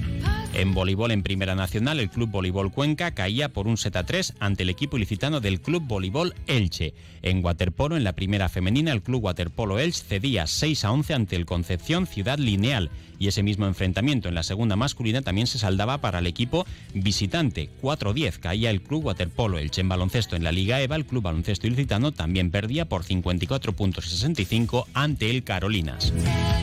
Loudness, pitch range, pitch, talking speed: -25 LUFS, 95-125 Hz, 100 Hz, 185 wpm